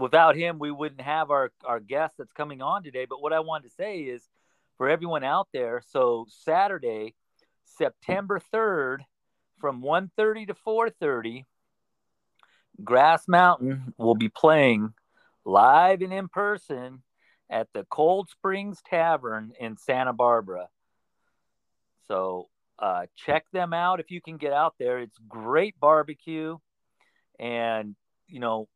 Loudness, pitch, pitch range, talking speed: -25 LUFS, 155 Hz, 125-190 Hz, 140 wpm